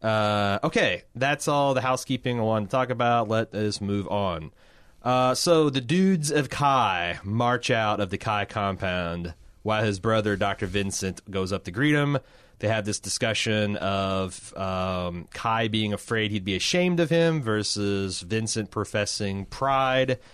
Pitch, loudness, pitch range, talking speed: 105 Hz, -25 LUFS, 100-130 Hz, 160 wpm